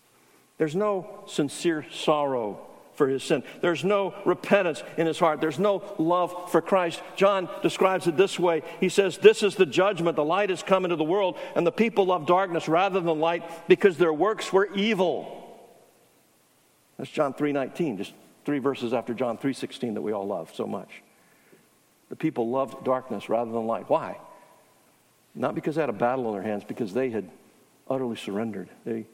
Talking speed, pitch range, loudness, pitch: 180 wpm, 135-190 Hz, -26 LUFS, 165 Hz